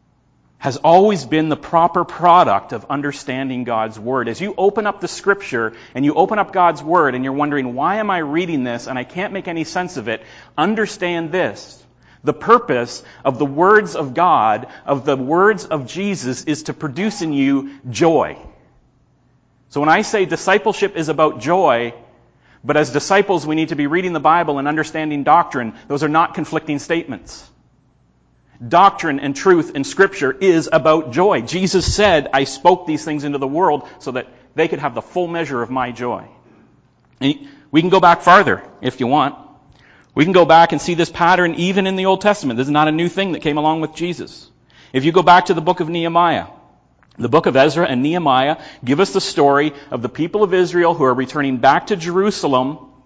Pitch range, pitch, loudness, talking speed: 135-180 Hz, 155 Hz, -16 LUFS, 200 wpm